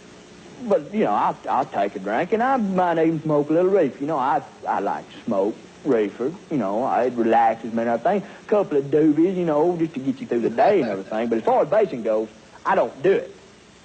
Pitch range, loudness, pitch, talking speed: 115-185 Hz, -22 LUFS, 150 Hz, 245 wpm